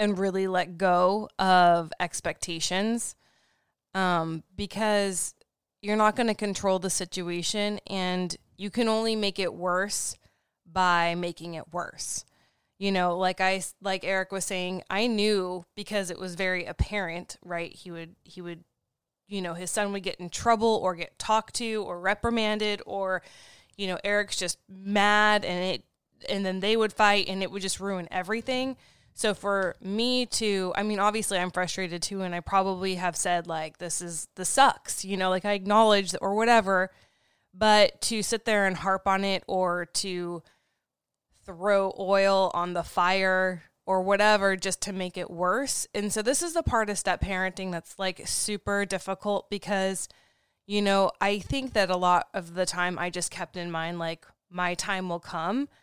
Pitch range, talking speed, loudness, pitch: 180-205 Hz, 175 wpm, -27 LUFS, 190 Hz